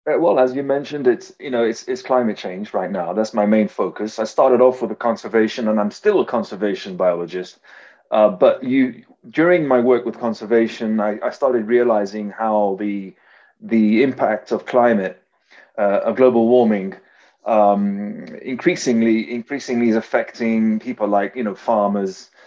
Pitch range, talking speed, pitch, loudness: 105-130 Hz, 165 wpm, 115 Hz, -18 LUFS